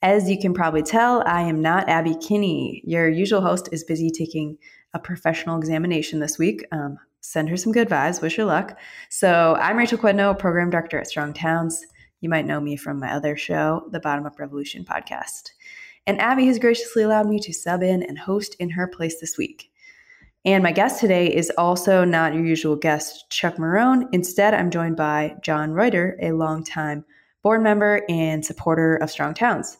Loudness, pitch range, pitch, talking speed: -21 LUFS, 160-200 Hz, 170 Hz, 190 wpm